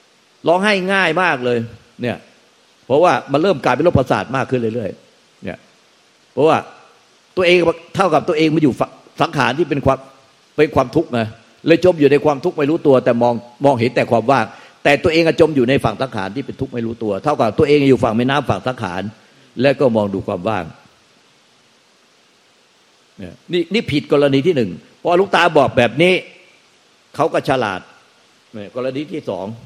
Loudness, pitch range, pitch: -16 LUFS, 120-160 Hz, 135 Hz